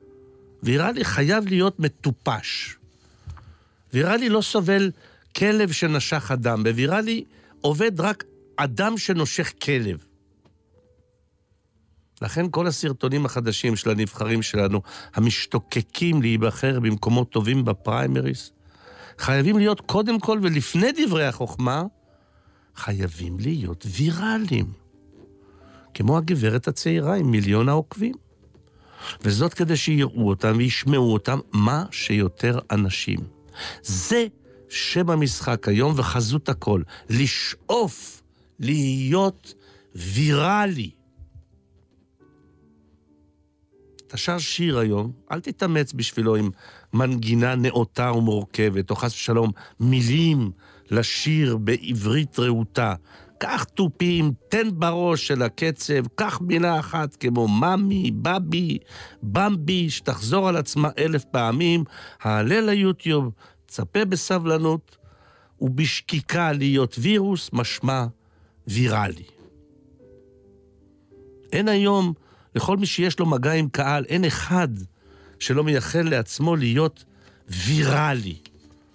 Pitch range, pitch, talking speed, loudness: 105-165 Hz, 130 Hz, 95 wpm, -23 LUFS